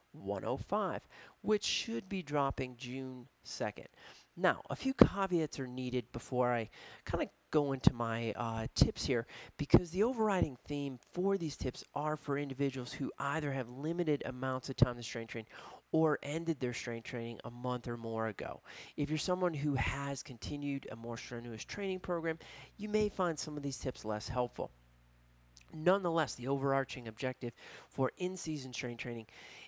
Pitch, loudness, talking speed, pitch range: 135 Hz, -36 LUFS, 165 wpm, 120-155 Hz